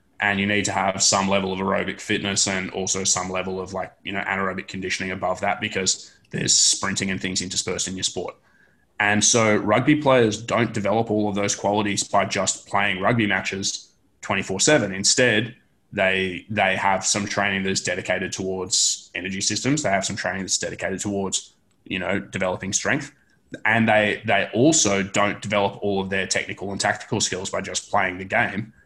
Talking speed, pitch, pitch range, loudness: 185 wpm, 100 Hz, 95-105 Hz, -22 LUFS